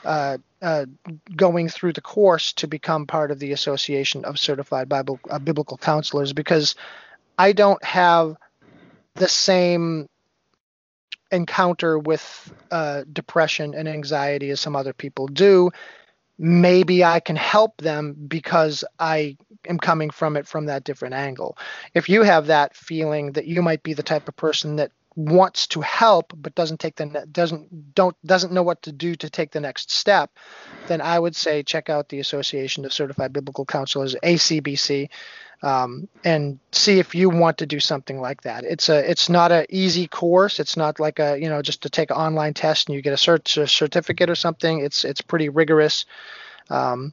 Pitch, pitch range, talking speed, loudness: 155 Hz, 145-170 Hz, 180 wpm, -20 LUFS